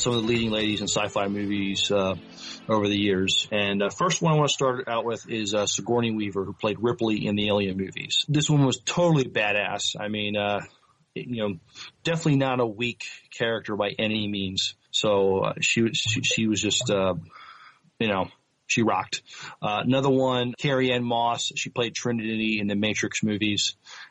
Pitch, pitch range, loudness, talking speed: 110 Hz, 100-125 Hz, -25 LUFS, 195 wpm